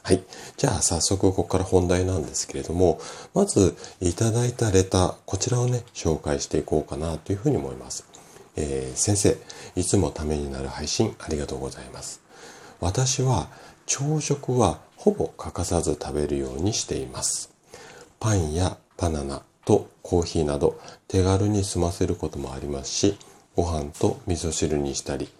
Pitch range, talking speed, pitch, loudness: 75-100 Hz, 330 characters per minute, 85 Hz, -25 LUFS